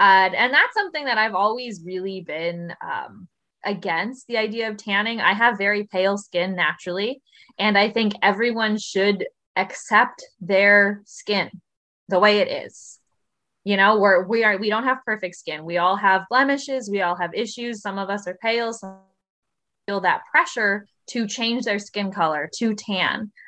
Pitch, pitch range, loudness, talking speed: 205 Hz, 190-225 Hz, -21 LUFS, 170 wpm